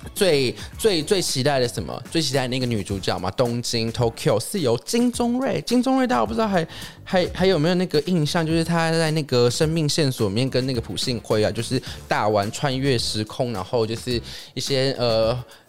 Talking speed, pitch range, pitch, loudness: 315 characters per minute, 115-165 Hz, 135 Hz, -22 LUFS